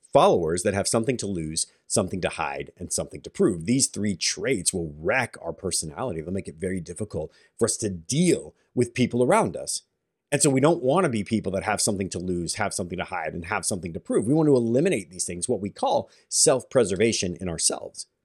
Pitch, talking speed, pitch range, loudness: 110 Hz, 225 wpm, 90-125 Hz, -25 LUFS